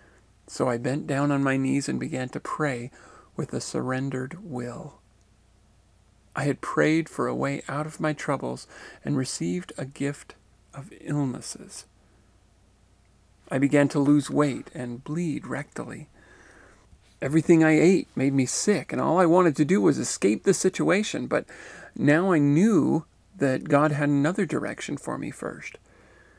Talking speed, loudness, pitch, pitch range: 150 wpm, -25 LUFS, 140 Hz, 105-155 Hz